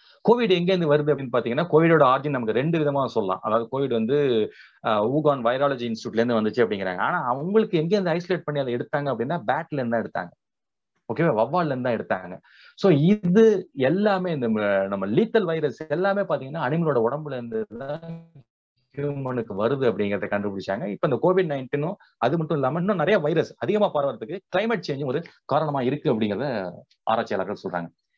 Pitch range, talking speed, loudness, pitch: 120-170 Hz, 150 wpm, -24 LUFS, 145 Hz